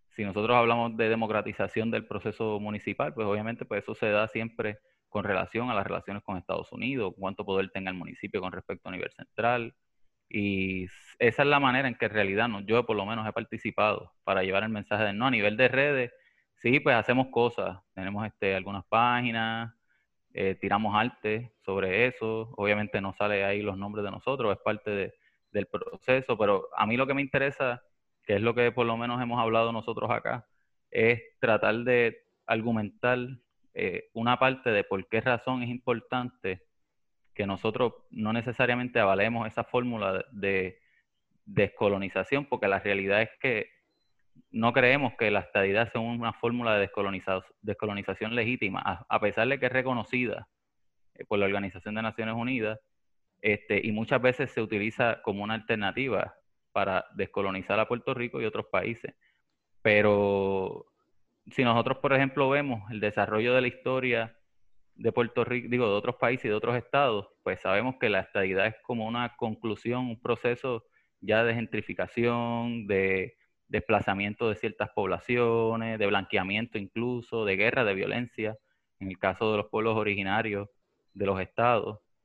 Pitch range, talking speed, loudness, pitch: 100-120 Hz, 165 wpm, -28 LUFS, 110 Hz